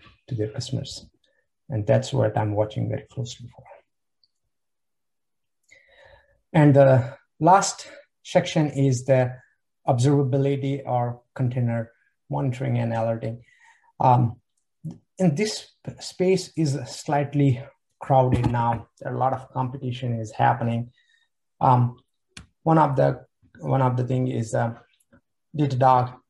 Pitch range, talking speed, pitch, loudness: 120-140 Hz, 110 wpm, 130 Hz, -23 LUFS